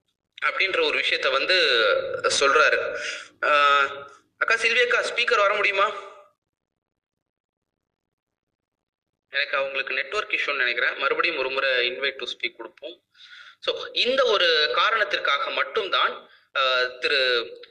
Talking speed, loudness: 95 wpm, -22 LUFS